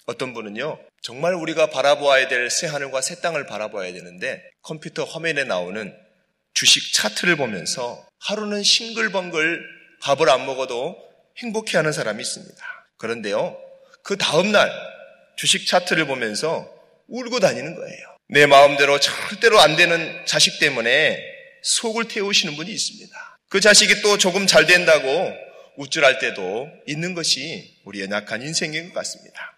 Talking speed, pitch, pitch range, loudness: 320 characters per minute, 180 Hz, 145-220 Hz, -18 LUFS